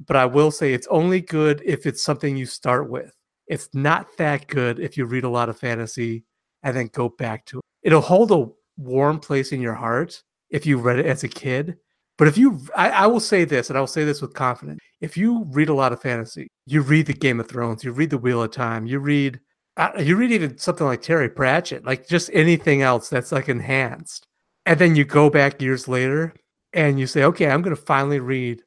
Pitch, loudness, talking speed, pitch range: 140 Hz, -20 LUFS, 230 wpm, 125-155 Hz